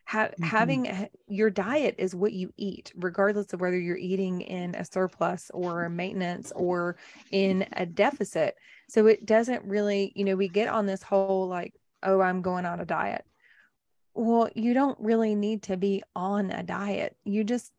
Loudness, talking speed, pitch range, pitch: -28 LUFS, 180 wpm, 185-215 Hz, 195 Hz